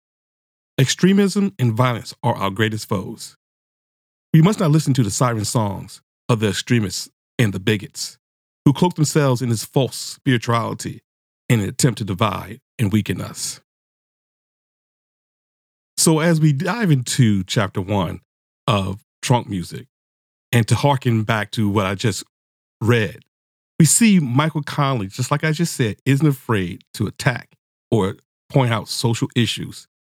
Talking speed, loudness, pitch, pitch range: 145 wpm, -19 LUFS, 120 Hz, 100-145 Hz